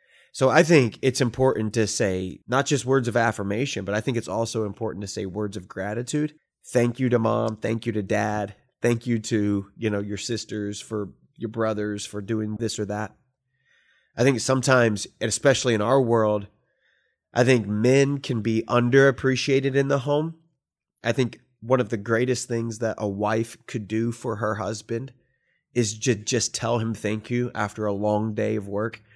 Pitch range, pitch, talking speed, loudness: 105-130 Hz, 115 Hz, 185 wpm, -24 LUFS